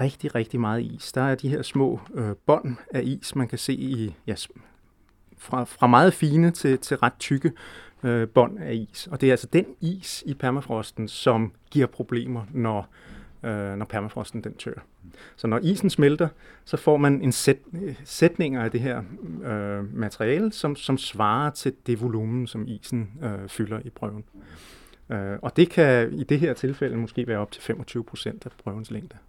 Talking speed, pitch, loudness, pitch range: 185 wpm, 125 Hz, -25 LUFS, 110-140 Hz